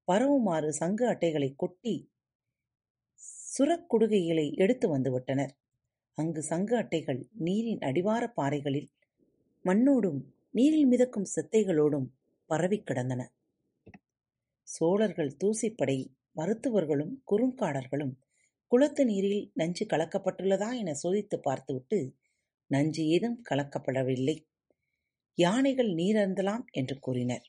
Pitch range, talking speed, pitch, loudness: 135-215 Hz, 80 wpm, 165 Hz, -30 LUFS